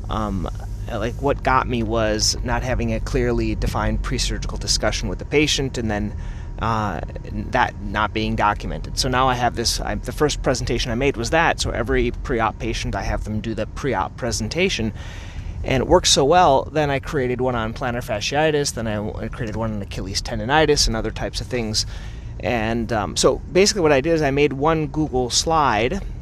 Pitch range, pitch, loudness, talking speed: 105-130 Hz, 115 Hz, -21 LUFS, 200 wpm